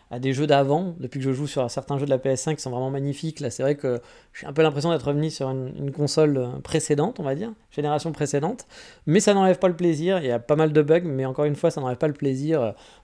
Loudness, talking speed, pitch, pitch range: -24 LUFS, 275 wpm, 145 Hz, 135-160 Hz